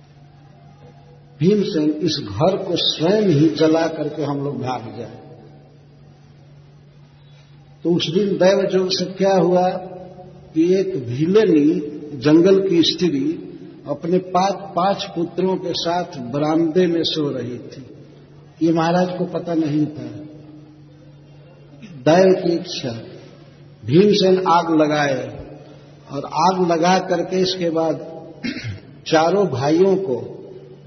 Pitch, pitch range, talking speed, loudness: 160 Hz, 145-180 Hz, 115 wpm, -18 LUFS